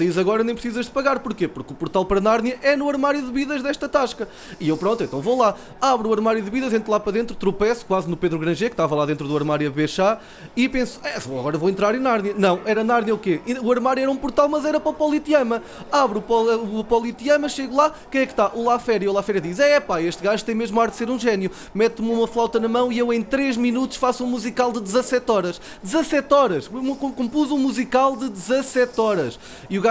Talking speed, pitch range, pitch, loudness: 245 wpm, 205-265 Hz, 235 Hz, -21 LUFS